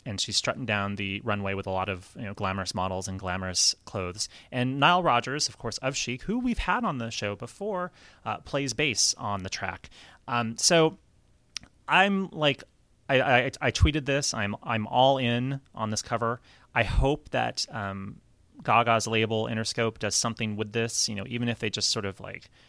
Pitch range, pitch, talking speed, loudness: 100-130 Hz, 115 Hz, 195 wpm, -27 LUFS